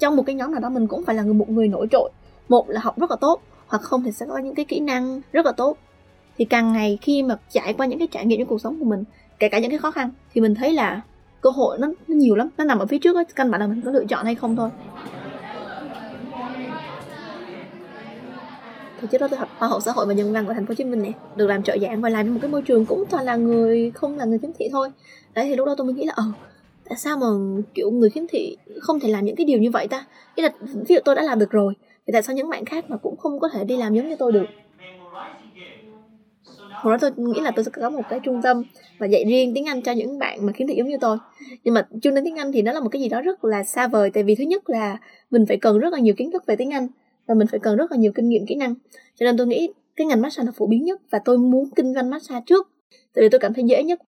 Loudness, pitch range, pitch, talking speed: -21 LUFS, 220-280 Hz, 245 Hz, 295 wpm